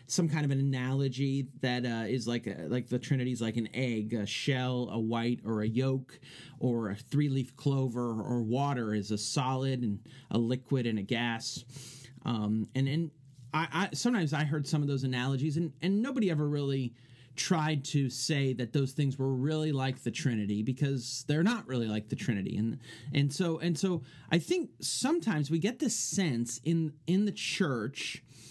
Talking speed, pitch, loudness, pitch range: 190 wpm, 130 Hz, -32 LUFS, 120-150 Hz